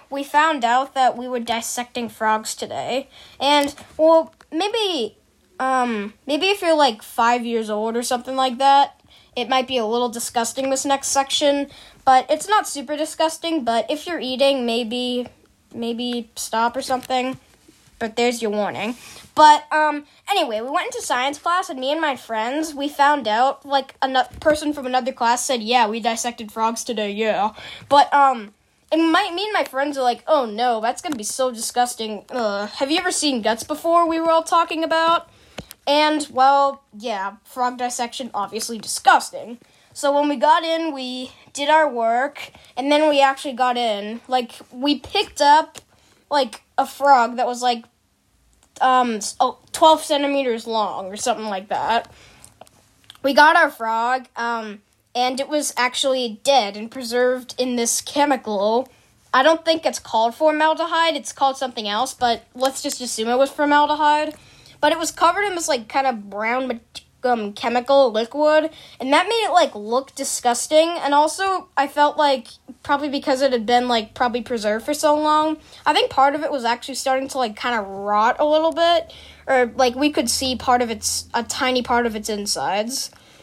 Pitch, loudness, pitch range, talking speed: 265 Hz, -20 LUFS, 235-300 Hz, 175 wpm